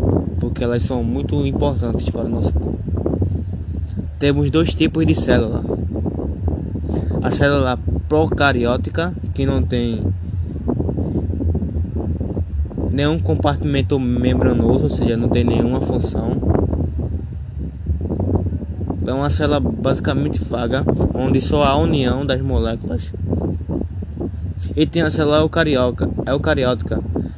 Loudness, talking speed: -19 LUFS, 100 wpm